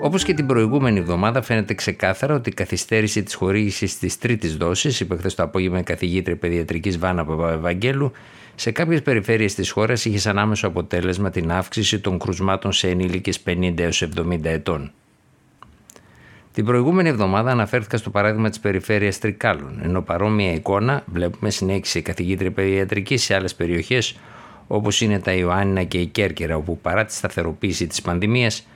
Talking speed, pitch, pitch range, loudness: 160 wpm, 100 Hz, 90-110 Hz, -21 LUFS